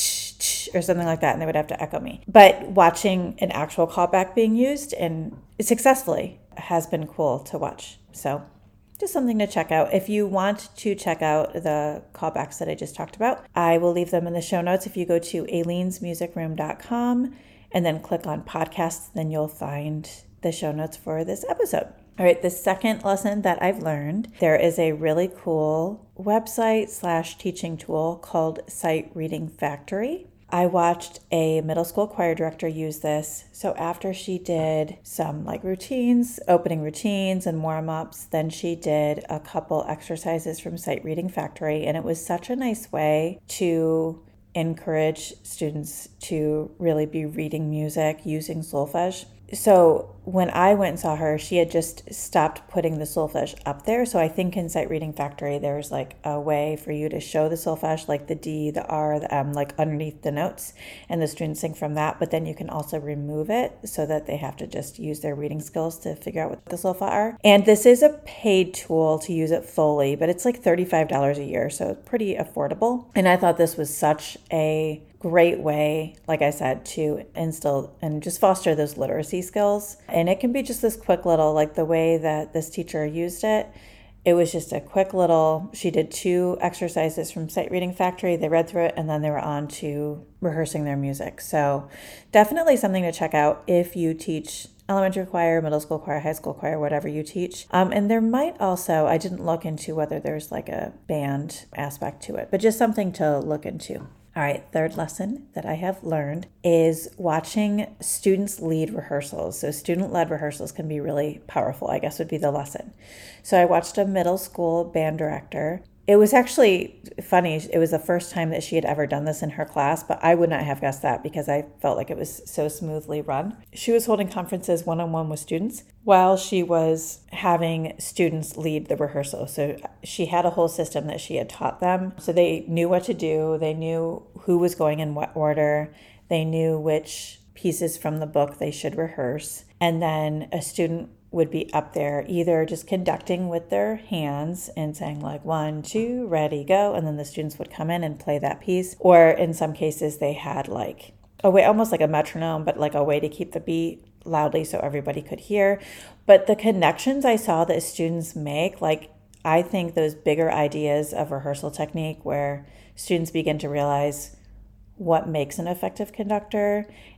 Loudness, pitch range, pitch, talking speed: -24 LUFS, 155-180 Hz, 165 Hz, 195 wpm